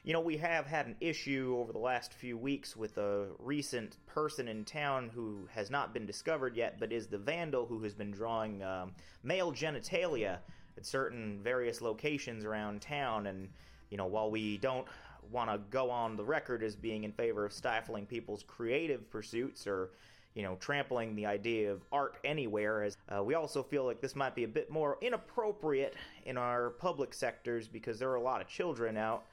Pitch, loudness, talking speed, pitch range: 115 Hz, -38 LUFS, 195 wpm, 105-140 Hz